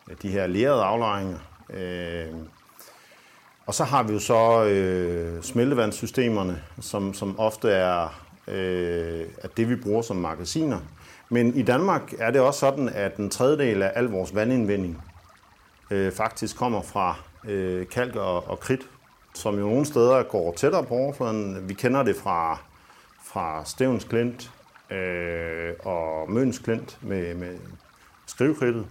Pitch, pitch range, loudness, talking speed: 100 Hz, 90-115 Hz, -25 LUFS, 120 wpm